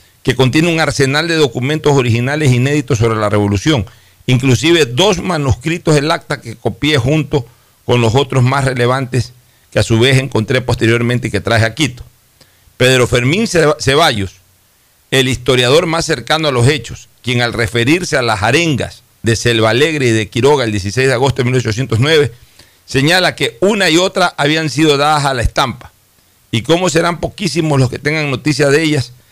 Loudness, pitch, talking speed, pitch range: -13 LUFS, 130 Hz, 170 wpm, 115-150 Hz